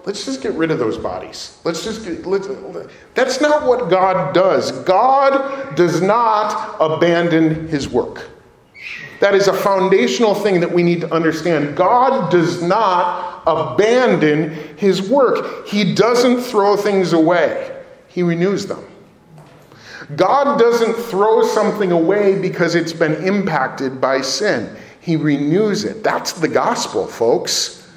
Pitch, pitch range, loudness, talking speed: 195 Hz, 170-235 Hz, -16 LUFS, 140 wpm